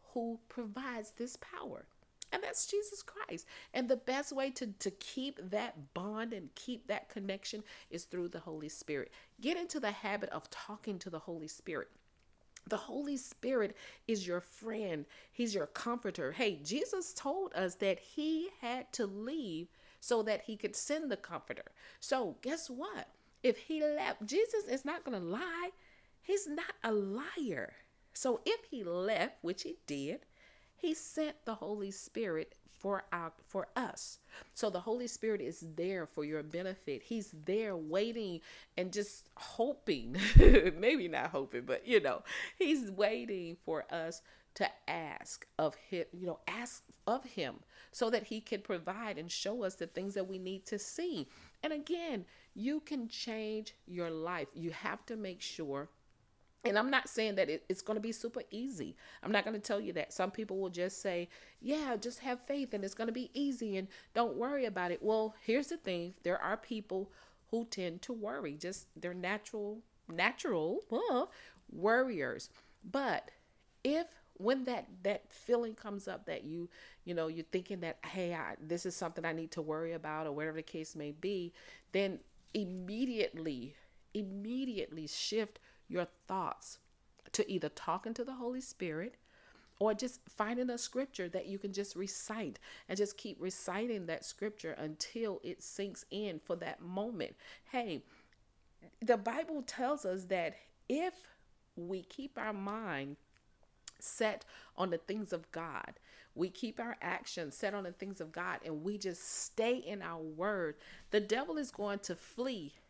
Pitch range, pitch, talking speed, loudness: 180-245 Hz, 210 Hz, 170 wpm, -38 LUFS